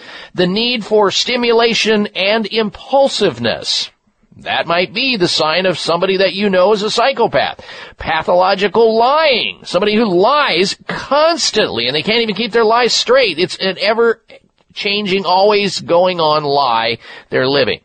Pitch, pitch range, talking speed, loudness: 210 Hz, 185-235 Hz, 145 wpm, -13 LUFS